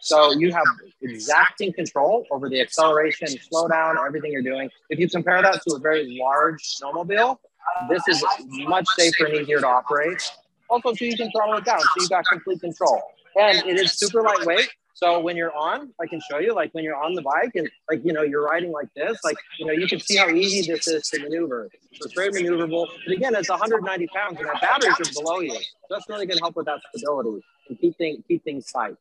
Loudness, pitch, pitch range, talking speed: -22 LUFS, 170 Hz, 155-195 Hz, 225 wpm